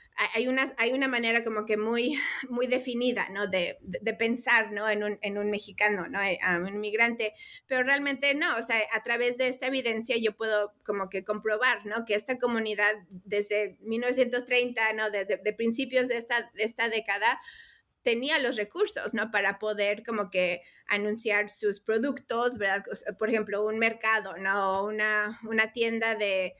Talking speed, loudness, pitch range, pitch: 175 wpm, -28 LUFS, 205-245 Hz, 220 Hz